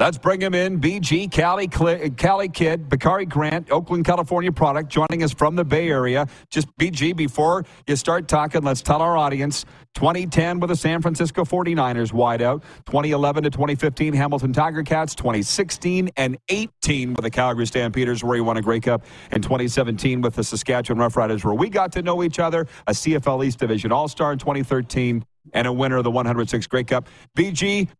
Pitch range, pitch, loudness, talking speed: 125-170 Hz, 150 Hz, -21 LUFS, 180 wpm